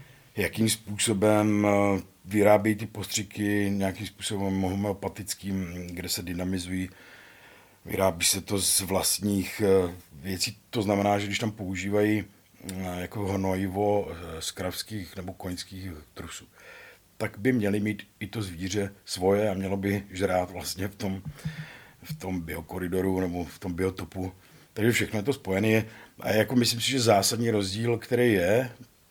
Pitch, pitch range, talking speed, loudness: 100 Hz, 95-105 Hz, 135 wpm, -27 LUFS